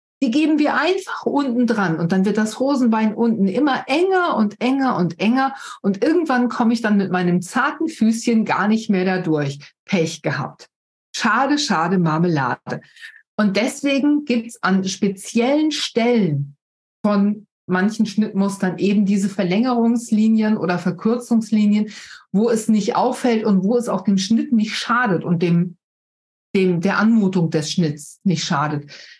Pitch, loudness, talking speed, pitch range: 215 Hz, -19 LUFS, 150 wpm, 185-240 Hz